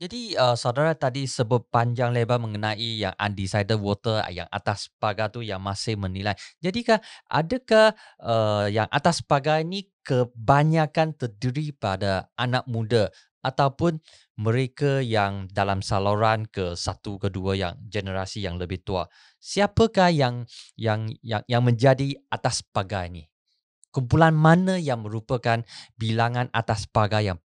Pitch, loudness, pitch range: 115 Hz, -24 LUFS, 105-140 Hz